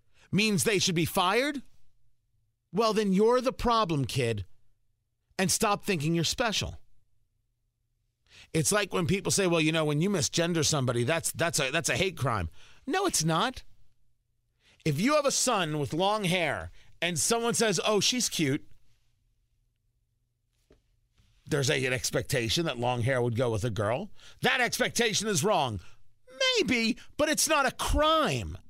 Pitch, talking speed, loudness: 150 Hz, 155 wpm, -27 LUFS